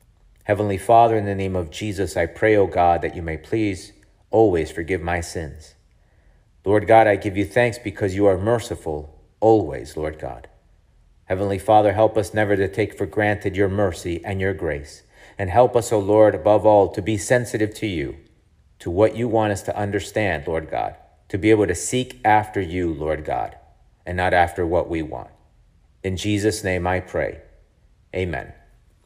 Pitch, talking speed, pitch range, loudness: 100 Hz, 180 wpm, 90-105 Hz, -21 LUFS